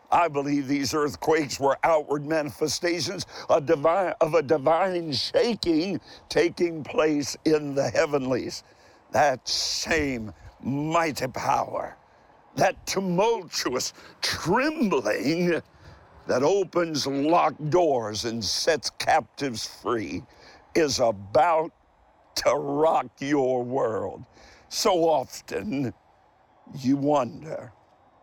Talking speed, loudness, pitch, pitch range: 85 wpm, -25 LUFS, 150 Hz, 130-165 Hz